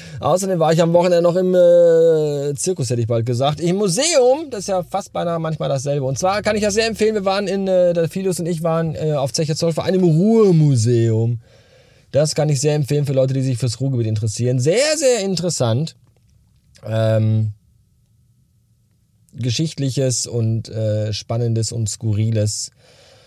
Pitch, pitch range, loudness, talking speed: 140 Hz, 115-175 Hz, -18 LUFS, 175 wpm